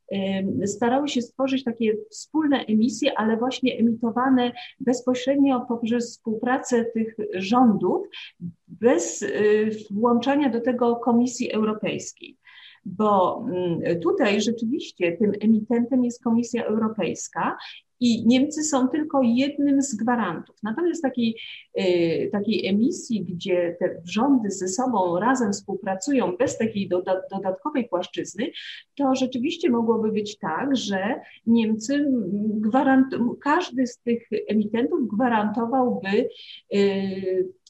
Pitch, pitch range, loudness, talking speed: 235 Hz, 210-260 Hz, -23 LUFS, 105 wpm